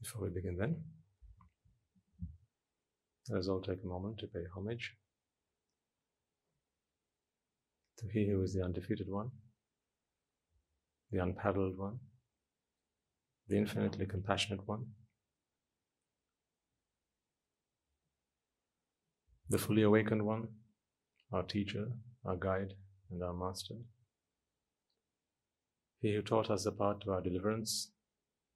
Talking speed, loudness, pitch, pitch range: 100 wpm, -38 LUFS, 100 Hz, 95-110 Hz